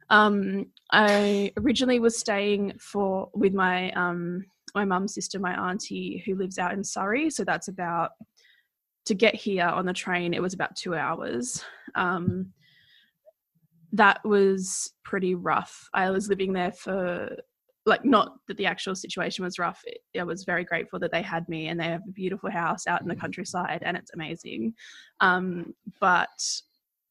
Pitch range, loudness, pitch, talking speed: 175-205 Hz, -27 LUFS, 190 Hz, 165 wpm